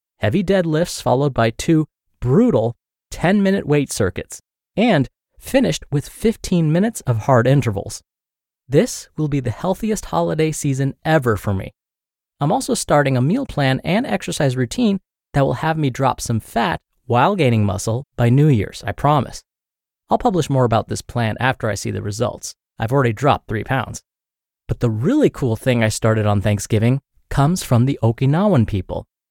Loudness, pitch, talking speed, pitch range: -19 LUFS, 130 Hz, 170 wpm, 115-155 Hz